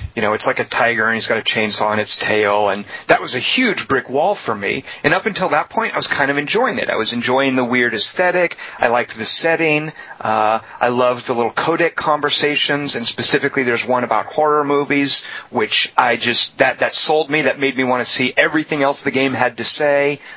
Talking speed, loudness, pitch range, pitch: 240 wpm, -16 LUFS, 115-150 Hz, 130 Hz